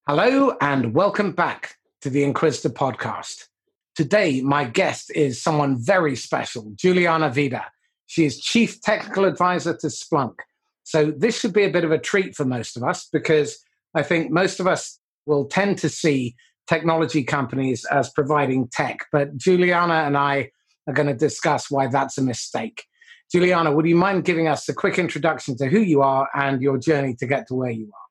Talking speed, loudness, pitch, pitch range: 185 wpm, -21 LUFS, 150 Hz, 140-175 Hz